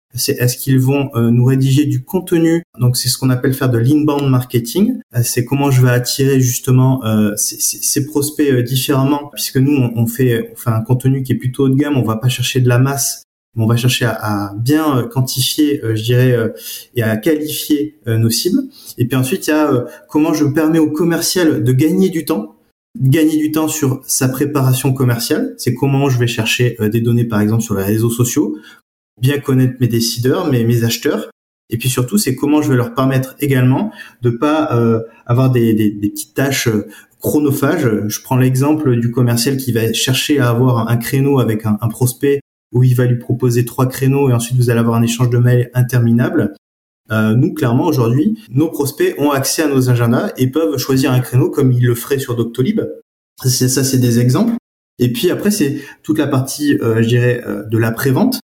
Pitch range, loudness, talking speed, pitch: 120-140 Hz, -15 LUFS, 200 wpm, 130 Hz